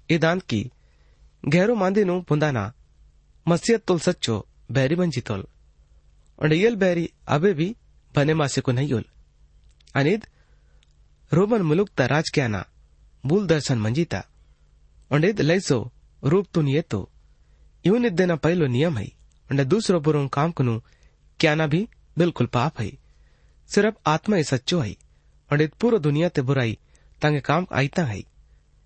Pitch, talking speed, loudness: 145 Hz, 115 wpm, -23 LUFS